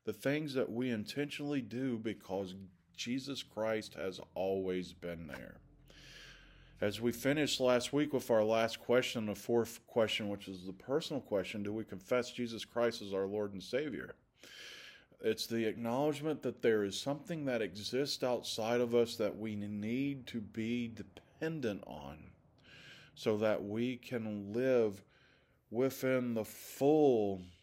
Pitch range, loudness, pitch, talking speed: 105-130 Hz, -36 LUFS, 115 Hz, 145 wpm